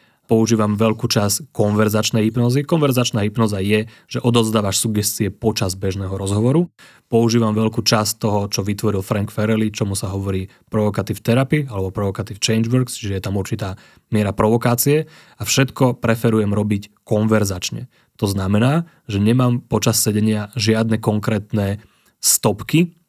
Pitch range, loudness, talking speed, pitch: 105-120 Hz, -19 LUFS, 135 wpm, 110 Hz